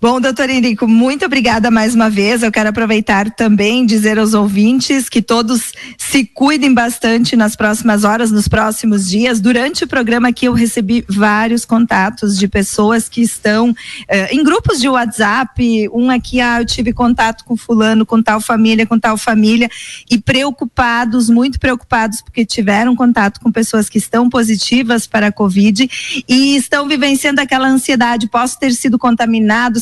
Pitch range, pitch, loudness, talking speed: 220-250 Hz, 235 Hz, -12 LUFS, 165 wpm